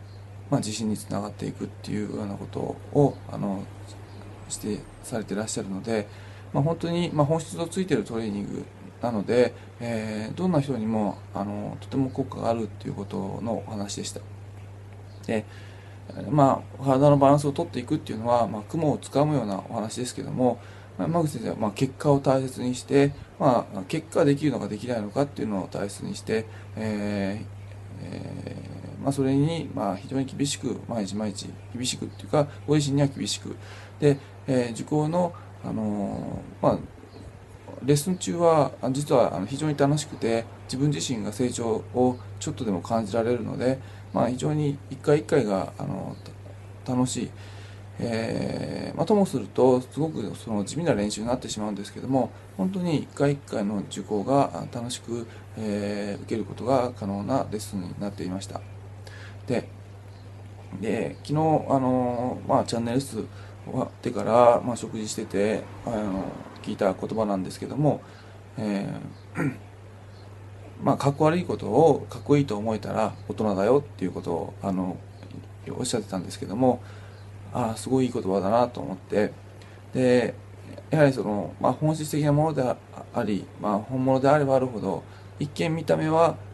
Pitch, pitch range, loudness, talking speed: 105 Hz, 100-130 Hz, -26 LUFS, 325 characters per minute